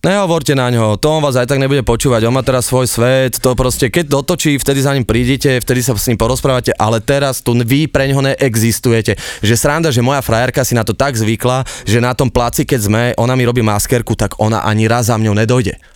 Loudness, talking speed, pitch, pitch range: -13 LUFS, 235 wpm, 125 Hz, 115-140 Hz